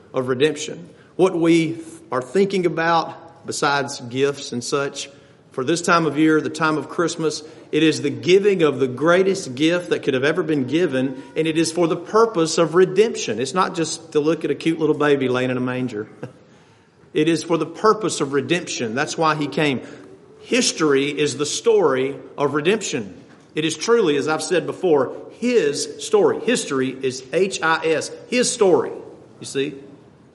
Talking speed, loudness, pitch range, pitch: 180 wpm, -20 LUFS, 140-180 Hz, 160 Hz